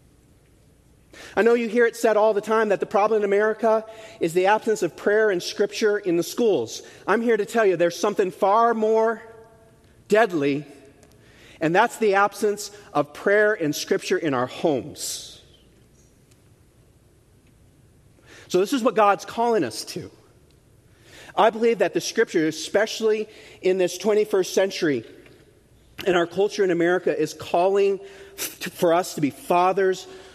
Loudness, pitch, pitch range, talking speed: -22 LUFS, 200 Hz, 175-220 Hz, 150 wpm